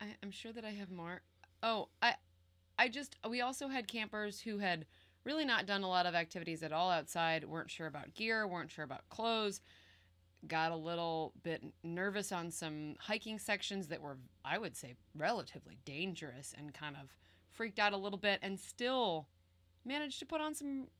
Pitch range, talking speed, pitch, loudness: 150-215 Hz, 185 wpm, 180 Hz, -39 LUFS